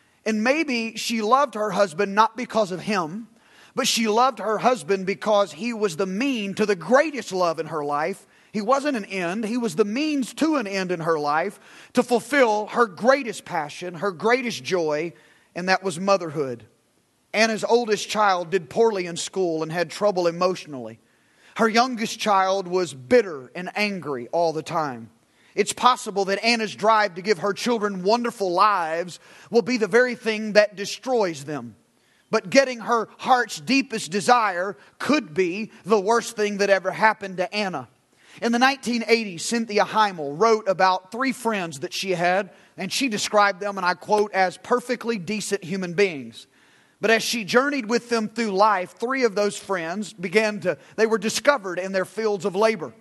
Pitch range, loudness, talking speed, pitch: 185-230 Hz, -23 LUFS, 175 wpm, 210 Hz